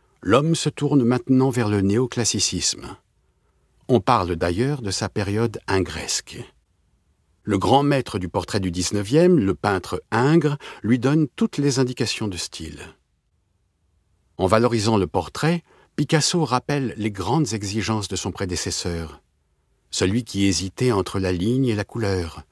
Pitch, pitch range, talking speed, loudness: 105 Hz, 90-130 Hz, 140 wpm, -22 LUFS